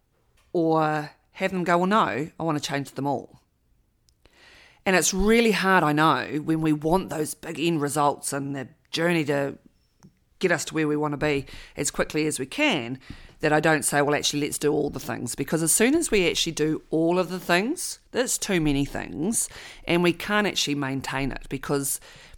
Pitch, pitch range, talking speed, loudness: 155 Hz, 140-175 Hz, 200 wpm, -24 LUFS